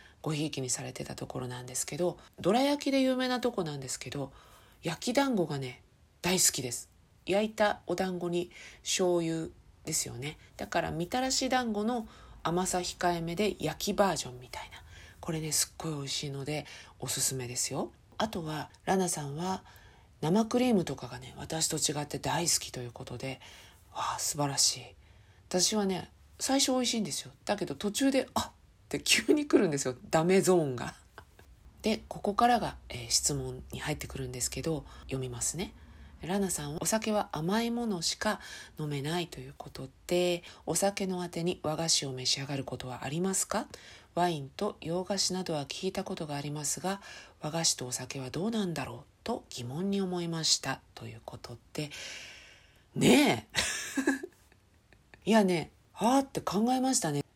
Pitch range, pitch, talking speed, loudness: 130-195 Hz, 160 Hz, 330 characters per minute, -31 LUFS